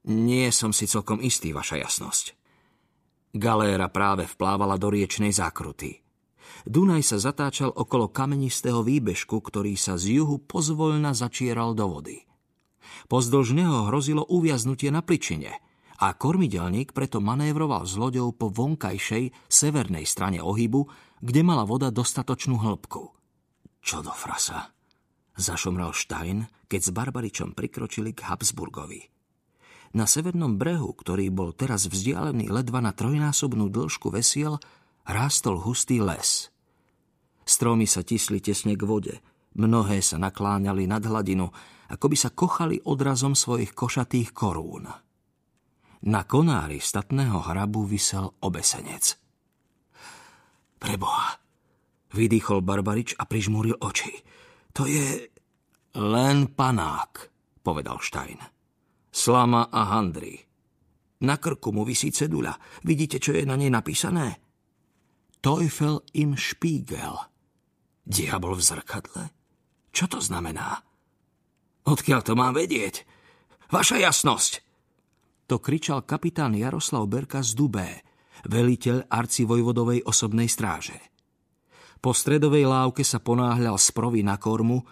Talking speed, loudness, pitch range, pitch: 110 wpm, -25 LUFS, 105-135 Hz, 120 Hz